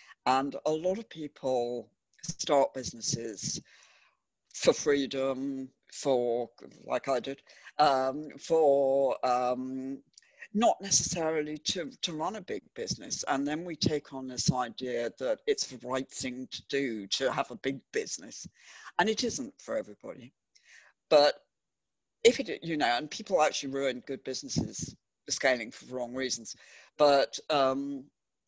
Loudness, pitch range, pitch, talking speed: -30 LUFS, 130-155 Hz, 135 Hz, 140 wpm